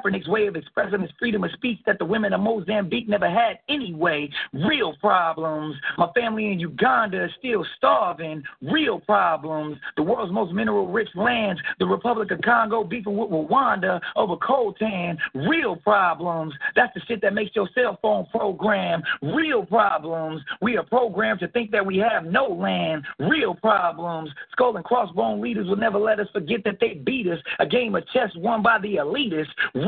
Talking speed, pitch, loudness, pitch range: 175 wpm, 205 Hz, -23 LUFS, 170-225 Hz